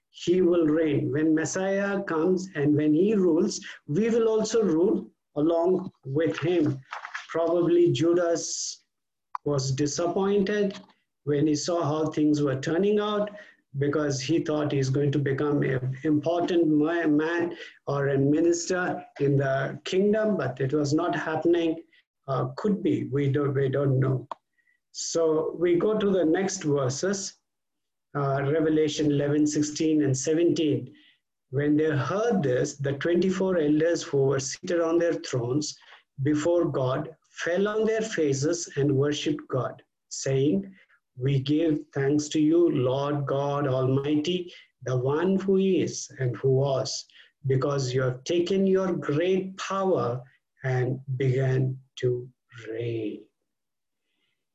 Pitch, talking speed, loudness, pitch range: 155 Hz, 130 wpm, -26 LUFS, 140-175 Hz